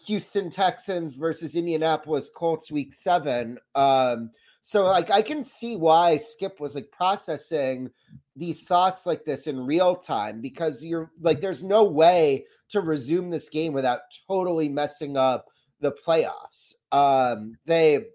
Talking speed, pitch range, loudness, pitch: 140 wpm, 145-190 Hz, -24 LUFS, 165 Hz